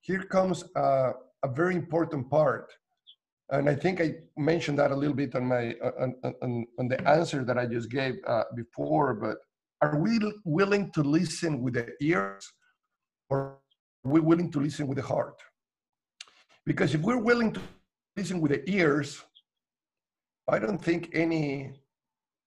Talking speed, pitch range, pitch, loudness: 160 wpm, 135-170 Hz, 145 Hz, -28 LUFS